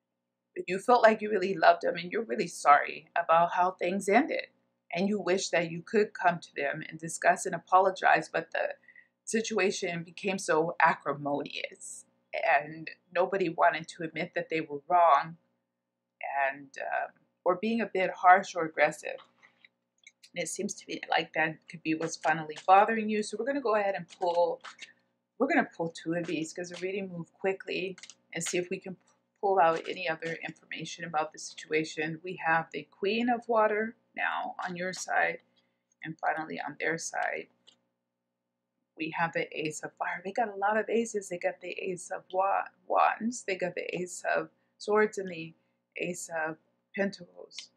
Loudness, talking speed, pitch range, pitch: -30 LUFS, 180 wpm, 155-195 Hz, 175 Hz